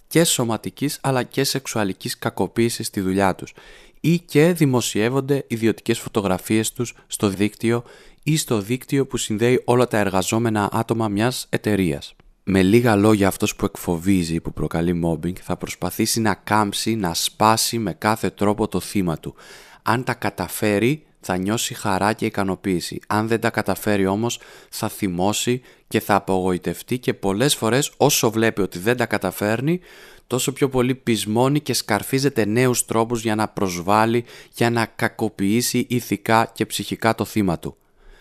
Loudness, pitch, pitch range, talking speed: -21 LUFS, 110 Hz, 100-120 Hz, 150 wpm